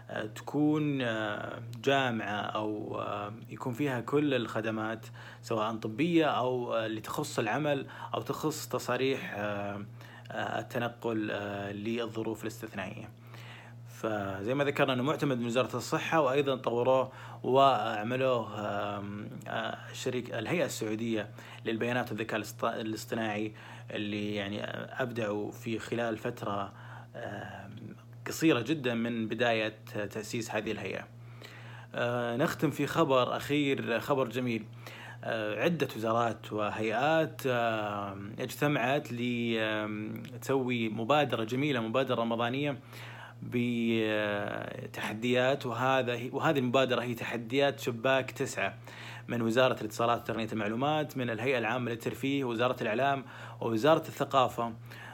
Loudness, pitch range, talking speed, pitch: -32 LUFS, 110-130 Hz, 95 wpm, 120 Hz